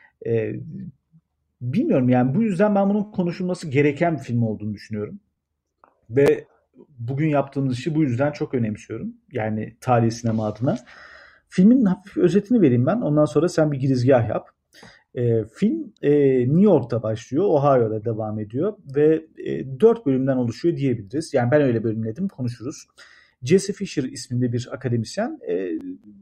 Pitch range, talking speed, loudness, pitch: 120-185 Hz, 140 wpm, -21 LUFS, 140 Hz